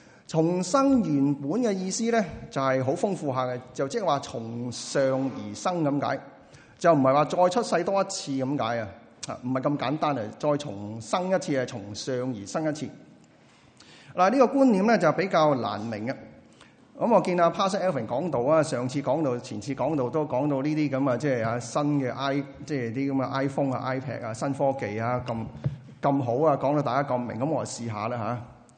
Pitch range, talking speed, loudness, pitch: 125-155 Hz, 305 characters per minute, -26 LUFS, 140 Hz